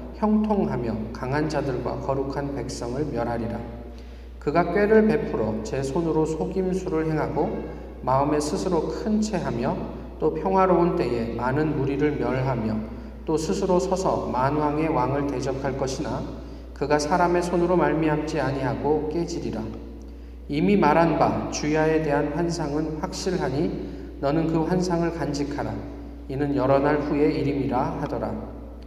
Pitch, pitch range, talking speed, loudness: 150 Hz, 130-170 Hz, 290 characters per minute, -24 LUFS